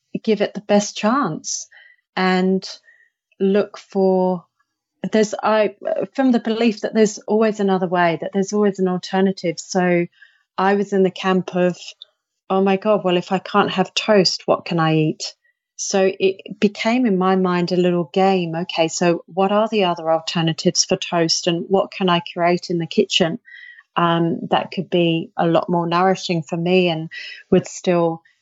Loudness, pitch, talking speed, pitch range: -19 LUFS, 190 Hz, 175 wpm, 175-205 Hz